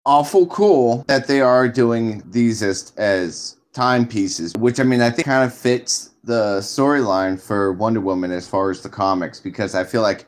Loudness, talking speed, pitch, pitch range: -18 LUFS, 185 wpm, 120 Hz, 95-130 Hz